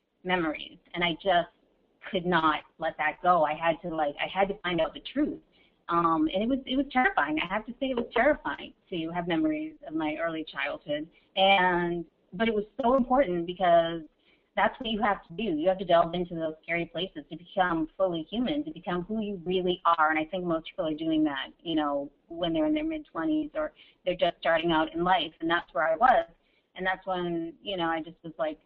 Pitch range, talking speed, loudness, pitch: 165-245 Hz, 230 wpm, -28 LUFS, 180 Hz